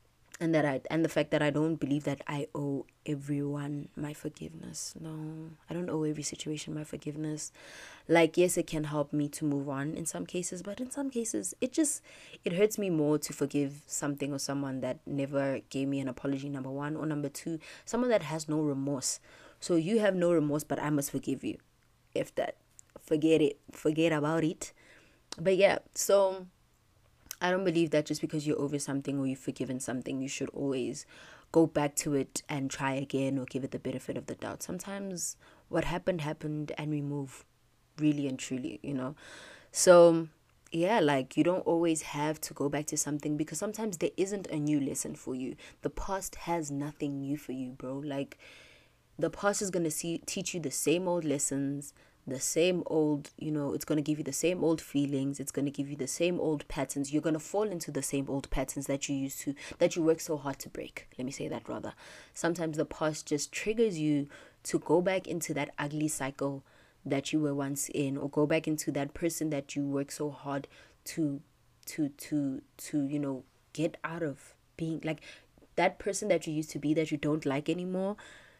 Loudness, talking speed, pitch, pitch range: -32 LUFS, 205 wpm, 150 Hz, 140-165 Hz